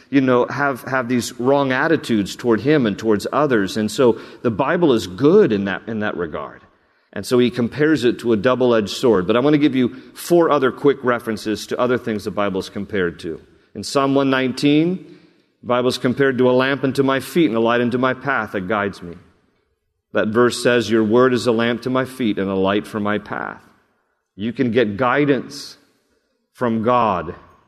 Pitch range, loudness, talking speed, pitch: 110-135 Hz, -18 LUFS, 210 wpm, 120 Hz